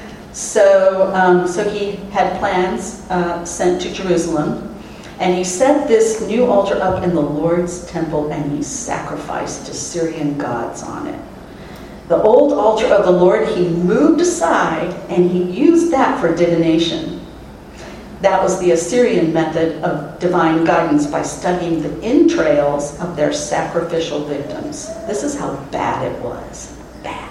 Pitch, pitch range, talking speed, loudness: 180 Hz, 165-195 Hz, 145 wpm, -16 LUFS